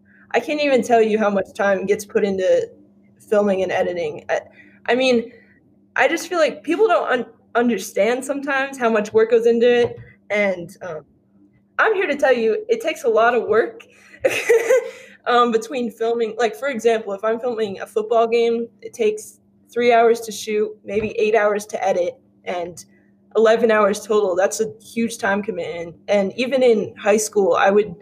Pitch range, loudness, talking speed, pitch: 210-255 Hz, -19 LUFS, 180 wpm, 230 Hz